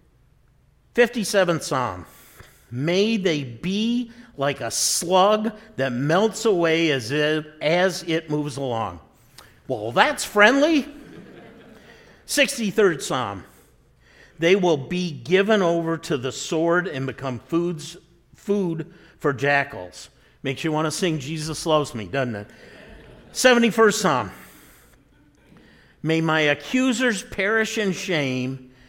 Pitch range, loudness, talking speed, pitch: 135-200 Hz, -22 LUFS, 110 wpm, 165 Hz